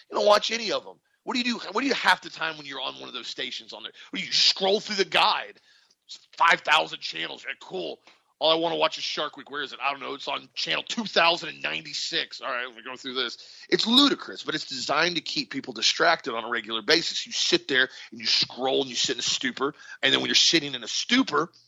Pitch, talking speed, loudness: 210 Hz, 255 wpm, -24 LUFS